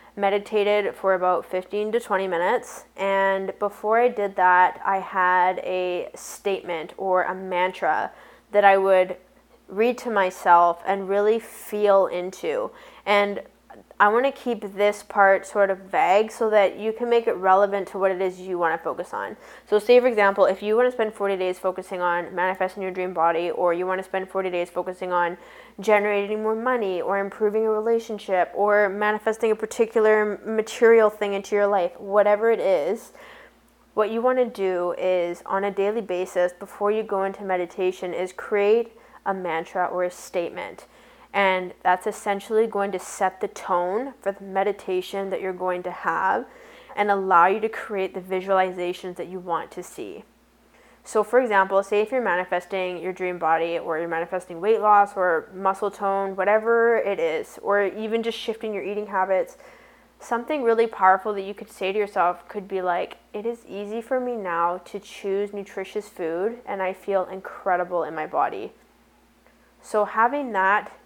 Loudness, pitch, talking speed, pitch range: -23 LUFS, 195 Hz, 175 wpm, 185-215 Hz